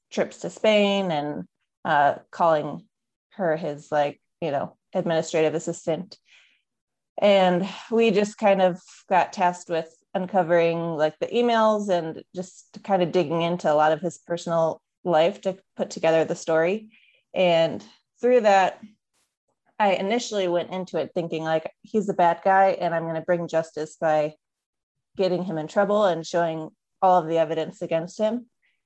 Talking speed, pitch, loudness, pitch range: 155 wpm, 180 Hz, -24 LUFS, 160-200 Hz